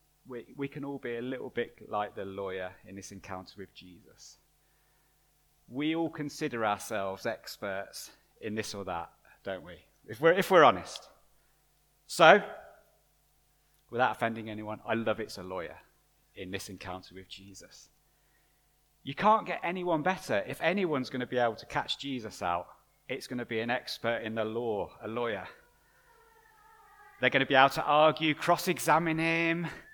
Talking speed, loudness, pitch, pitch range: 165 wpm, -30 LUFS, 125 Hz, 105-160 Hz